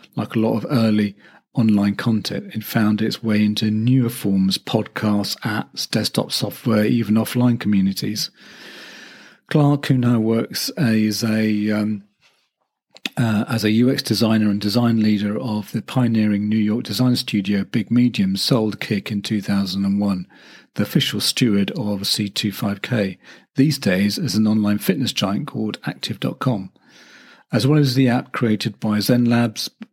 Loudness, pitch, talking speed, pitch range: -20 LUFS, 110 Hz, 145 wpm, 105-120 Hz